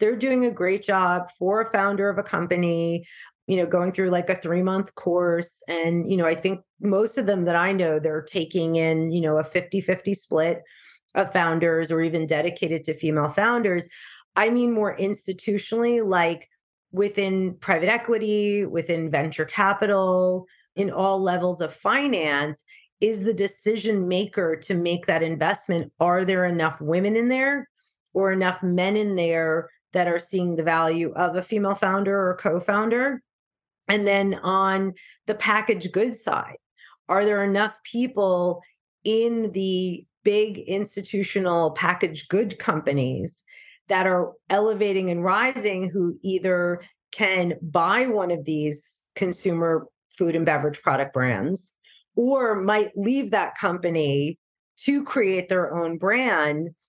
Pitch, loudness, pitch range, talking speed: 185 Hz, -23 LUFS, 170-205 Hz, 145 wpm